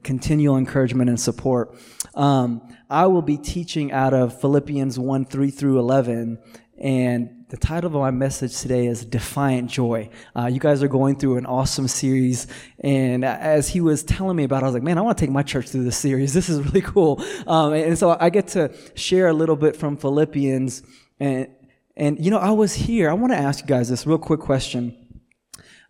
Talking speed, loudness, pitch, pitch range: 205 wpm, -21 LUFS, 135 Hz, 125-150 Hz